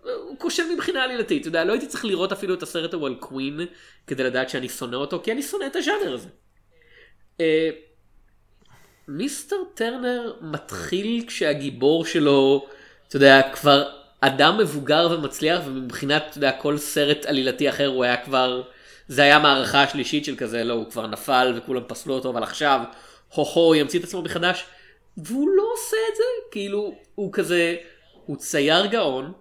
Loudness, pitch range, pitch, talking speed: -22 LUFS, 135-200 Hz, 150 Hz, 165 wpm